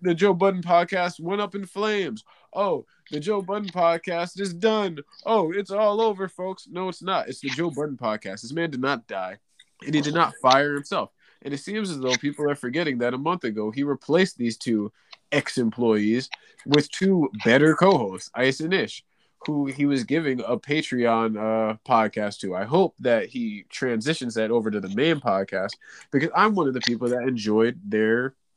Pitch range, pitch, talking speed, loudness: 120-185 Hz, 145 Hz, 195 wpm, -24 LUFS